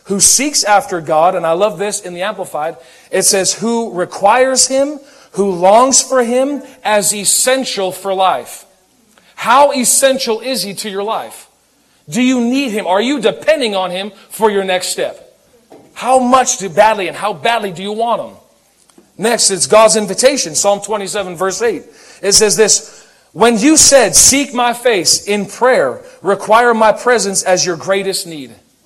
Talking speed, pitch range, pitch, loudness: 170 wpm, 190-255 Hz, 215 Hz, -12 LUFS